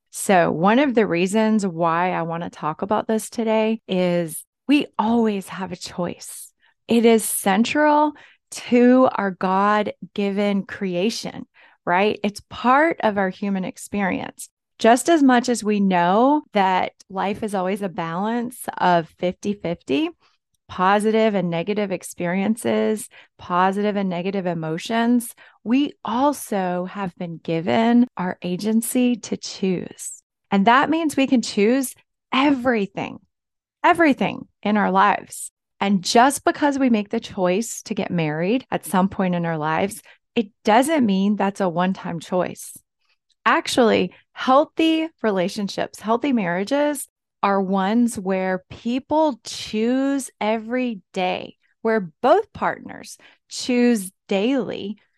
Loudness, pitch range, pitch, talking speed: -21 LUFS, 185-245 Hz, 215 Hz, 130 wpm